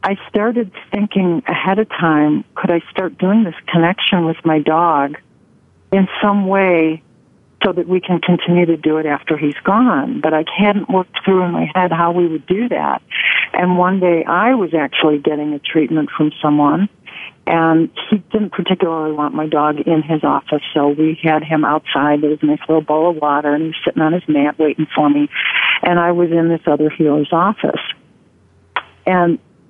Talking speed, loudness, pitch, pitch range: 190 wpm, -15 LUFS, 165 Hz, 155-185 Hz